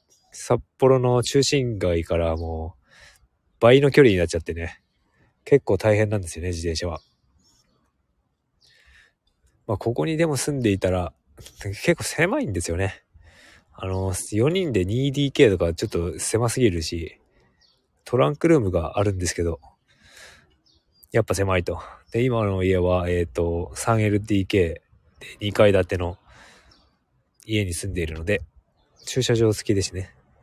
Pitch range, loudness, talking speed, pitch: 85-115 Hz, -22 LUFS, 255 characters per minute, 95 Hz